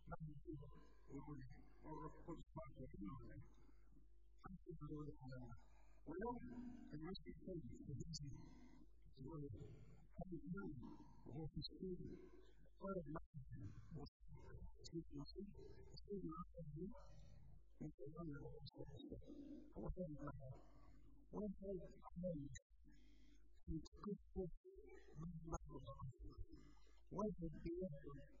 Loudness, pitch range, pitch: -55 LUFS, 140-185 Hz, 160 Hz